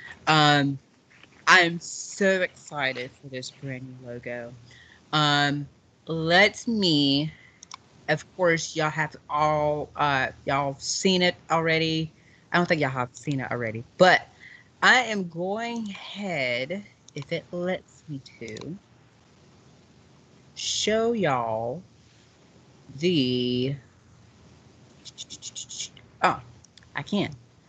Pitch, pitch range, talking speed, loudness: 145 Hz, 130-175 Hz, 100 wpm, -24 LUFS